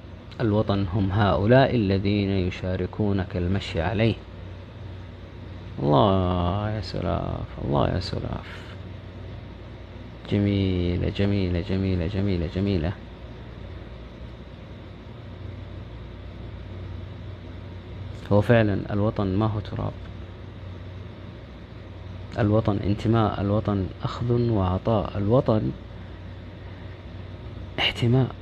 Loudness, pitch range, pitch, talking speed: -24 LUFS, 90-105 Hz, 100 Hz, 65 wpm